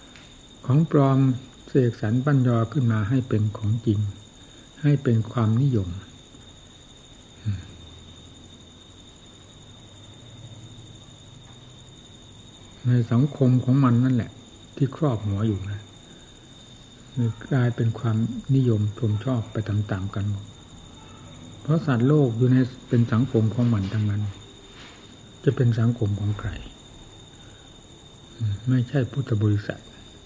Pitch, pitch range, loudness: 115 Hz, 105-125 Hz, -24 LUFS